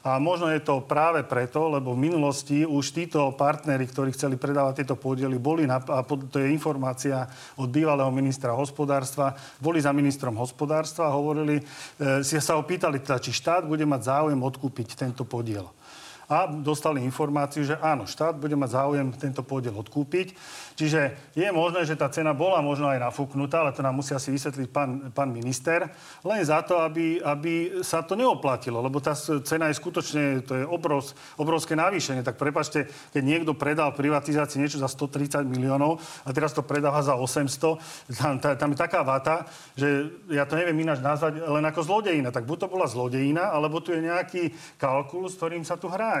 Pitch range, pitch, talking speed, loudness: 135-155 Hz, 145 Hz, 180 wpm, -26 LUFS